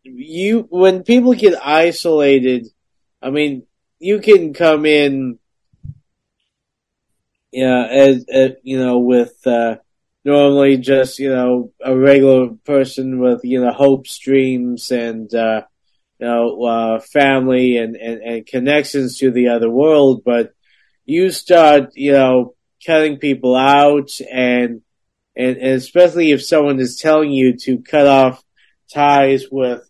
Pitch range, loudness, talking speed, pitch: 125-145 Hz, -14 LUFS, 135 wpm, 130 Hz